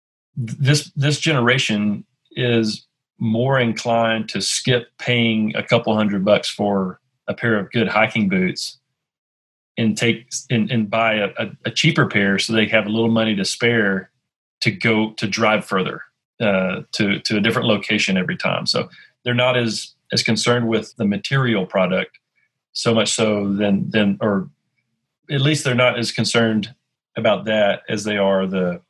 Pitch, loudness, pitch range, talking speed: 115 Hz, -19 LUFS, 105-120 Hz, 165 wpm